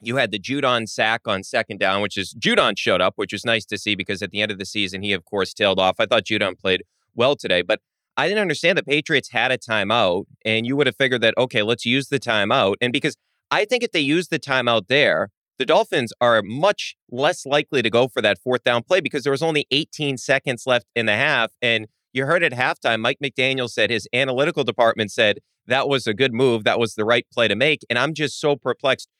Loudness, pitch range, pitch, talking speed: -20 LUFS, 110-140 Hz, 120 Hz, 245 wpm